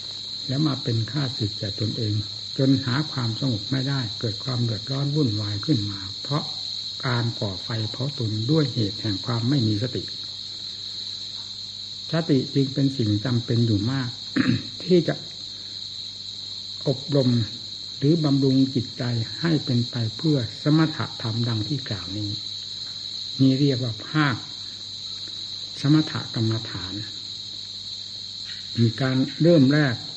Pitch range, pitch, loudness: 100-135 Hz, 115 Hz, -25 LUFS